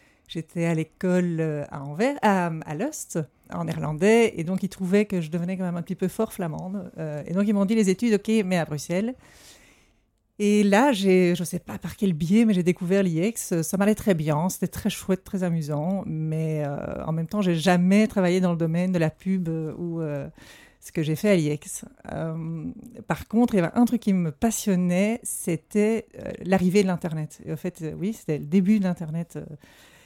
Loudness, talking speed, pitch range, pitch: -24 LUFS, 215 wpm, 165-205 Hz, 180 Hz